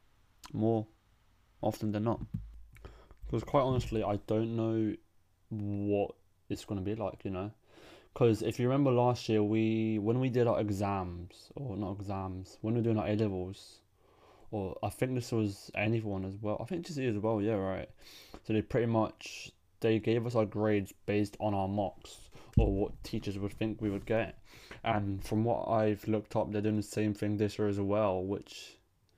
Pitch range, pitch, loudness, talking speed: 100-115 Hz, 105 Hz, -33 LUFS, 190 wpm